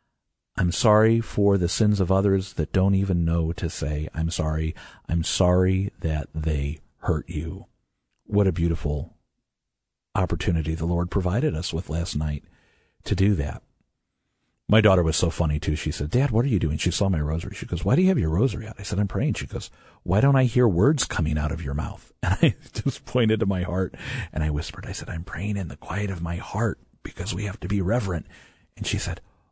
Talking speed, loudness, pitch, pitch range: 215 wpm, -24 LUFS, 90 Hz, 80-105 Hz